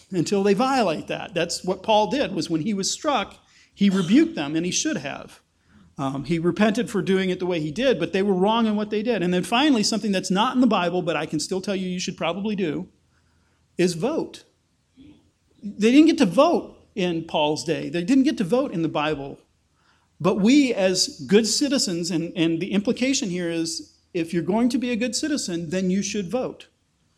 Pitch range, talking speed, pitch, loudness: 170-240 Hz, 215 wpm, 195 Hz, -22 LUFS